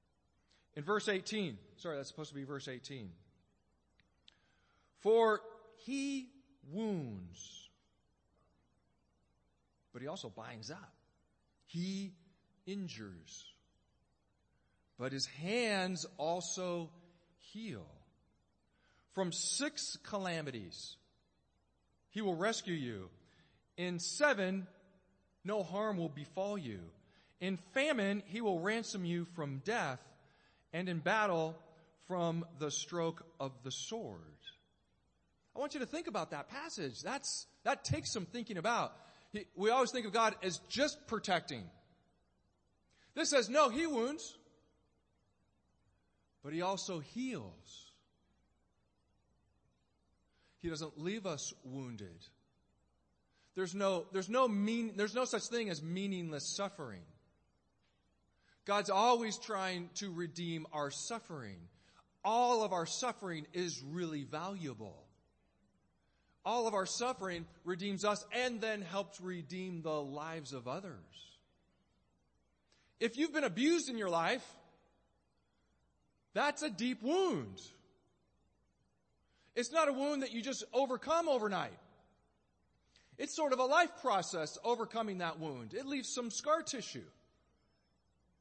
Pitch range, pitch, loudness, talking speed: 155-230 Hz, 185 Hz, -38 LUFS, 115 wpm